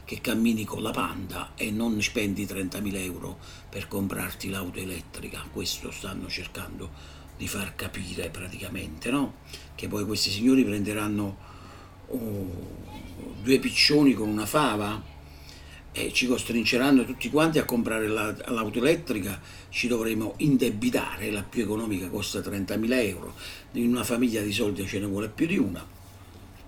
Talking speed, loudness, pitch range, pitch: 140 wpm, -27 LUFS, 95-110 Hz, 100 Hz